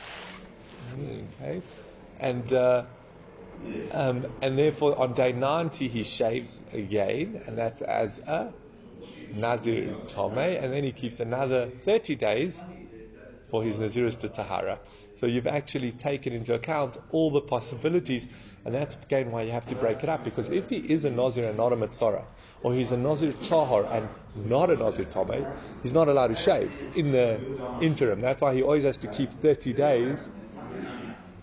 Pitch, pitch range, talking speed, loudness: 130 Hz, 120-145 Hz, 165 wpm, -28 LUFS